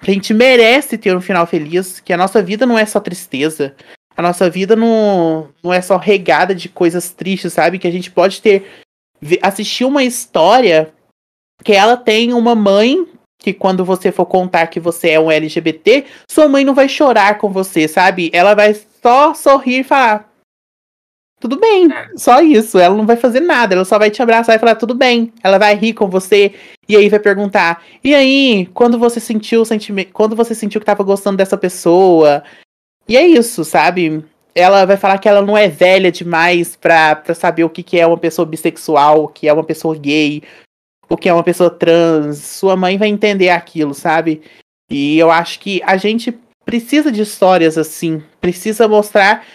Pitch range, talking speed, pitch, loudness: 170-220 Hz, 190 wpm, 190 Hz, -11 LUFS